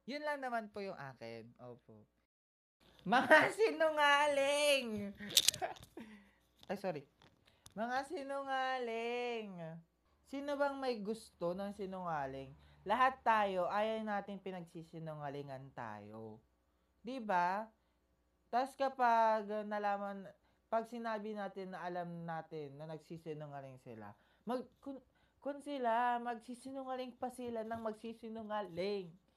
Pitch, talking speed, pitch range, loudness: 205 Hz, 100 wpm, 160-245 Hz, -37 LUFS